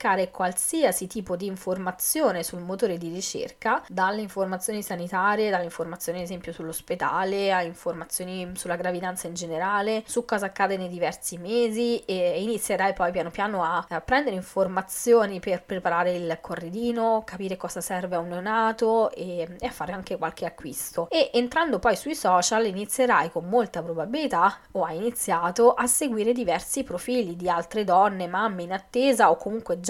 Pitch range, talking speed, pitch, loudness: 175-225 Hz, 155 wpm, 190 Hz, -26 LUFS